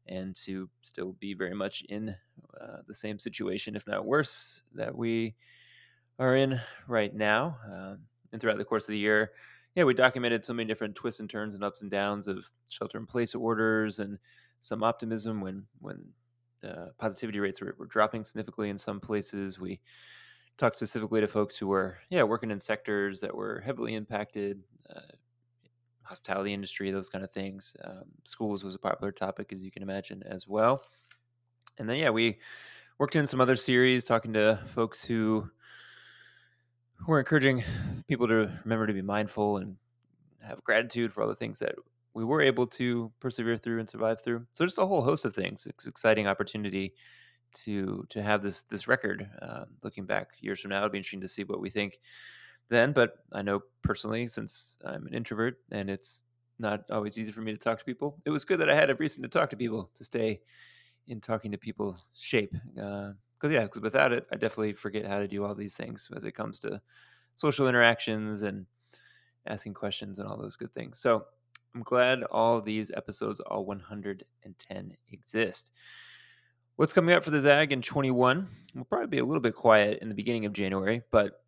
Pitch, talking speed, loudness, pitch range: 110 Hz, 190 wpm, -30 LUFS, 100-120 Hz